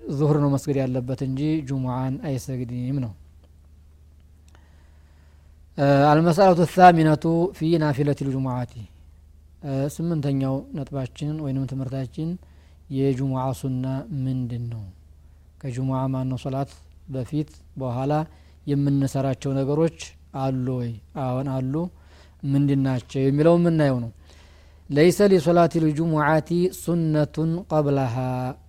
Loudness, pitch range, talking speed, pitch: -23 LUFS, 115-150 Hz, 95 wpm, 135 Hz